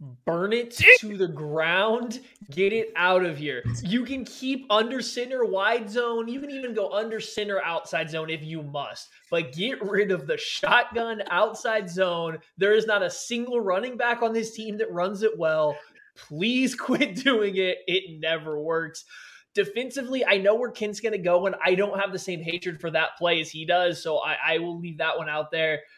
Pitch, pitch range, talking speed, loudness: 200 Hz, 165-235 Hz, 200 wpm, -25 LUFS